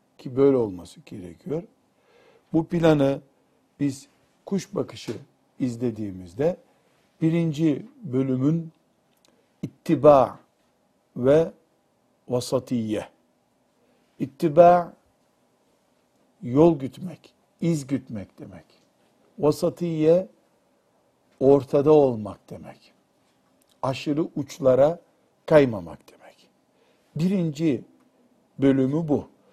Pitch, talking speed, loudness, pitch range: 145 Hz, 65 wpm, -23 LUFS, 130-165 Hz